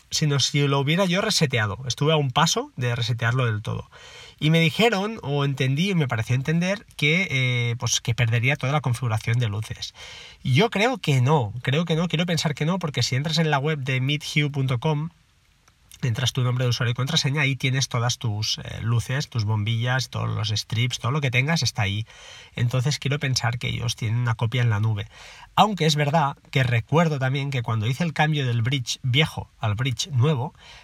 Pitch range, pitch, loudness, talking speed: 120-155 Hz, 130 Hz, -23 LUFS, 205 wpm